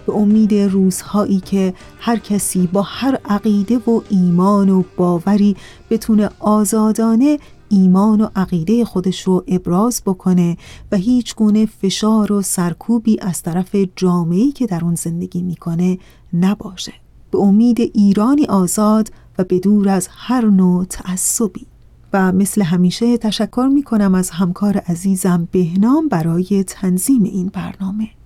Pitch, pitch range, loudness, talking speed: 200 Hz, 185-215 Hz, -16 LUFS, 125 wpm